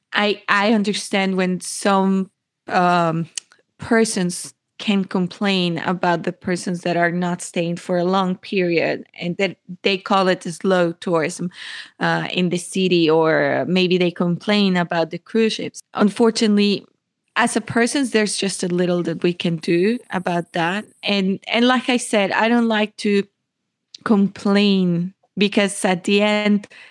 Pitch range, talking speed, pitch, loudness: 175-205 Hz, 150 wpm, 190 Hz, -19 LUFS